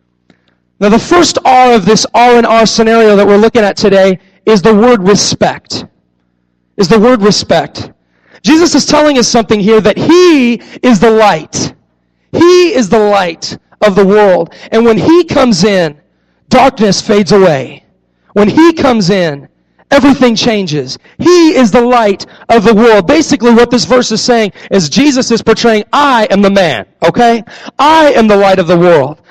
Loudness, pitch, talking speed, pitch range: -7 LUFS, 225 Hz, 170 wpm, 195-250 Hz